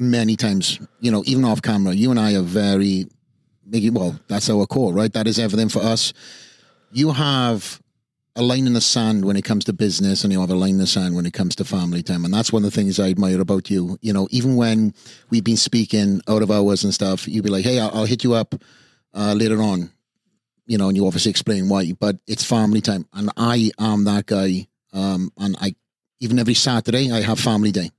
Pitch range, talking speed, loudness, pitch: 95-115 Hz, 230 wpm, -19 LUFS, 105 Hz